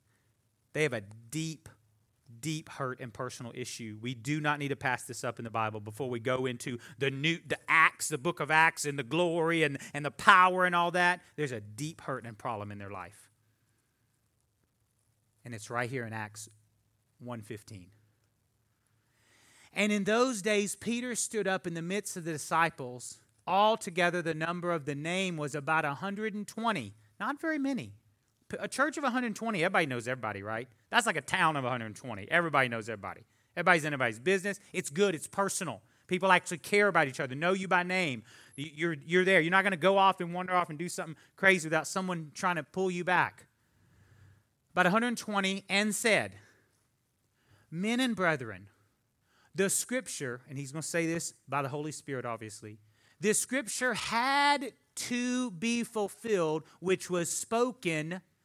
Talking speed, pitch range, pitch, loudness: 175 wpm, 115-185 Hz, 155 Hz, -30 LUFS